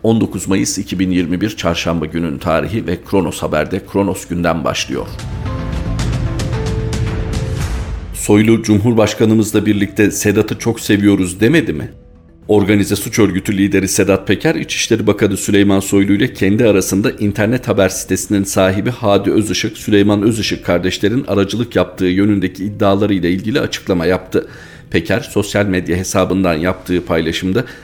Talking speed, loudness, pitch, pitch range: 120 wpm, -15 LUFS, 100 Hz, 95-105 Hz